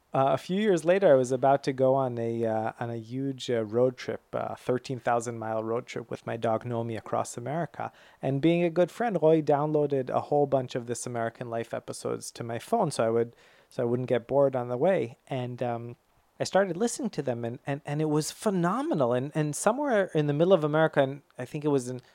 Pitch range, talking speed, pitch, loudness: 120-155 Hz, 240 wpm, 135 Hz, -28 LUFS